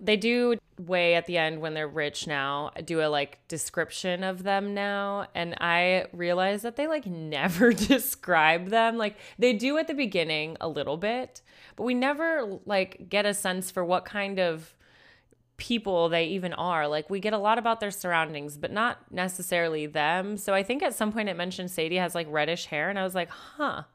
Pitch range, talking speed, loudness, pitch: 165-210 Hz, 200 wpm, -27 LUFS, 185 Hz